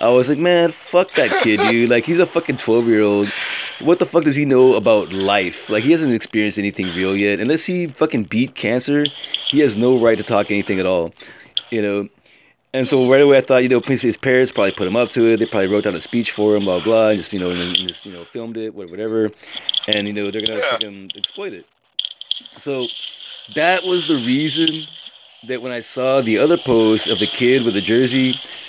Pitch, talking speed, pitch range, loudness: 120 Hz, 230 wpm, 105-140 Hz, -17 LUFS